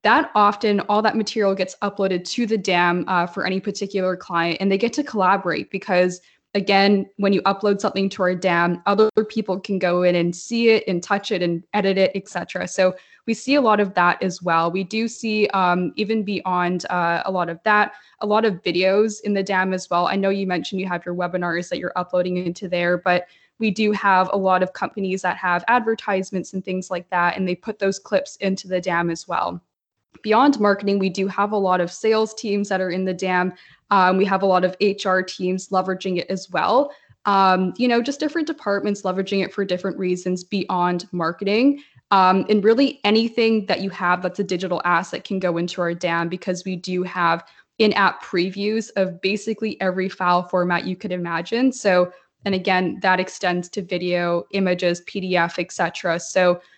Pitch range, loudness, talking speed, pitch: 180-205 Hz, -21 LUFS, 205 wpm, 190 Hz